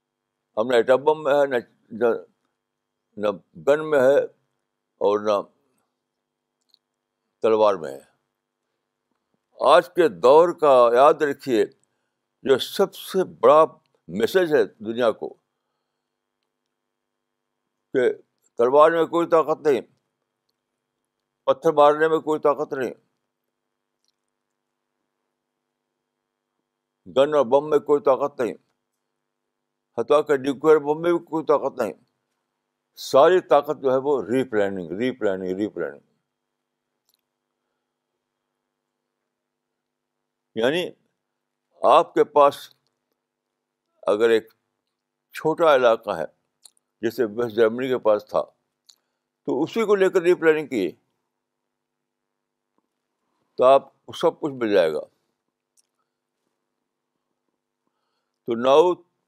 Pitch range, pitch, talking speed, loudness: 115-165 Hz, 140 Hz, 100 wpm, -21 LUFS